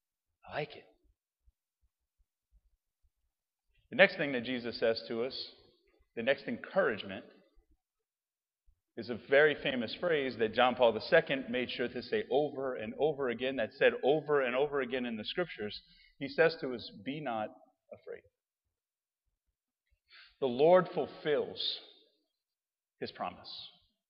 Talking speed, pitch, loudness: 130 wpm, 145 Hz, -32 LUFS